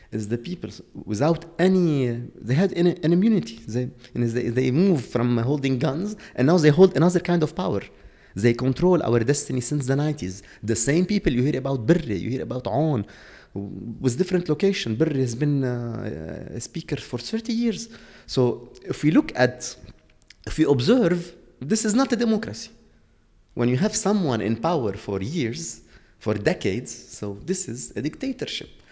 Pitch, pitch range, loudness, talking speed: 140 Hz, 120-175 Hz, -23 LUFS, 180 wpm